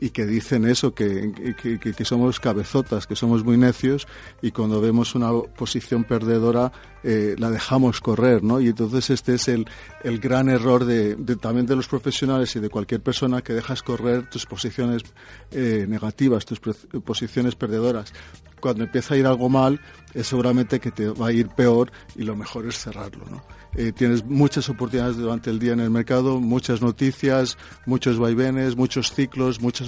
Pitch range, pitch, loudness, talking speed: 115-130 Hz, 120 Hz, -22 LUFS, 180 wpm